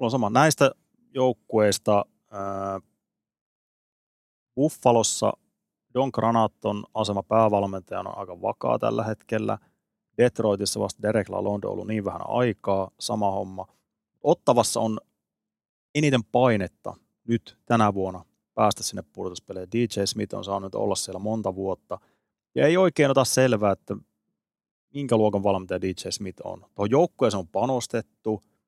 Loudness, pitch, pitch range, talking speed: -25 LUFS, 110 Hz, 100-120 Hz, 125 wpm